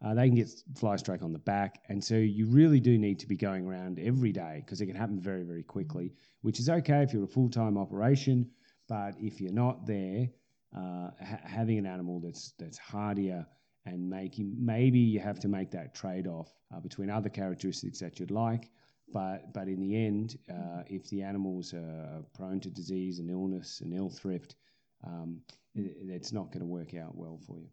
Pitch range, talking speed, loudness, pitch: 90-115 Hz, 210 wpm, -33 LUFS, 100 Hz